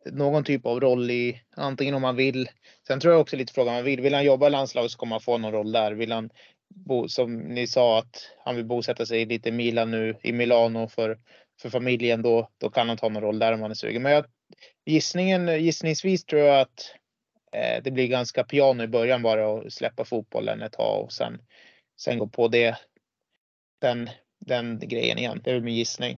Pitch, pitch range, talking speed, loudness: 120 Hz, 115-140 Hz, 220 wpm, -25 LUFS